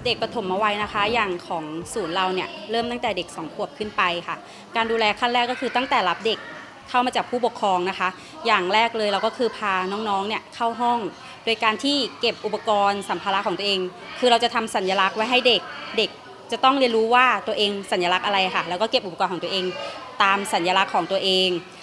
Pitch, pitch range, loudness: 215 Hz, 190-235 Hz, -22 LUFS